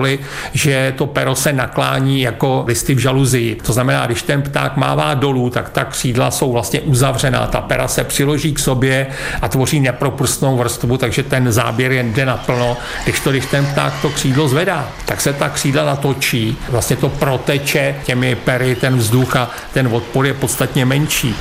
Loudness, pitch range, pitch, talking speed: -16 LUFS, 125-145 Hz, 135 Hz, 180 wpm